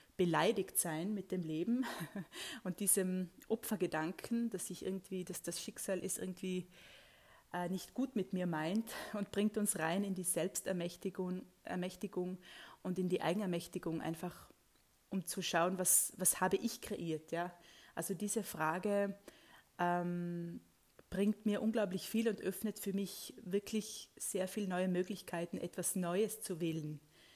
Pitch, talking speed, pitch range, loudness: 185 Hz, 140 wpm, 175-205 Hz, -38 LUFS